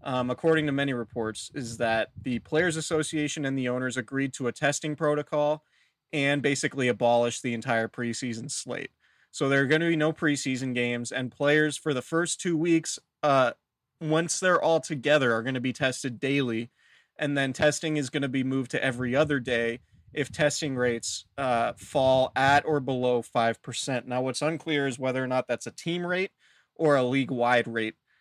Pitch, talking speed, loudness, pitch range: 135 Hz, 190 wpm, -27 LUFS, 125-150 Hz